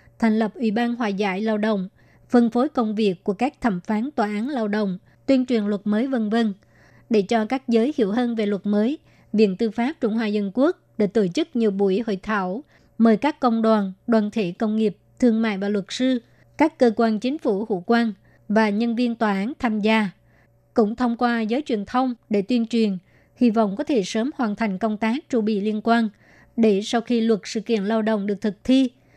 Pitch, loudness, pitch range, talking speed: 225 Hz, -22 LUFS, 210-240 Hz, 225 wpm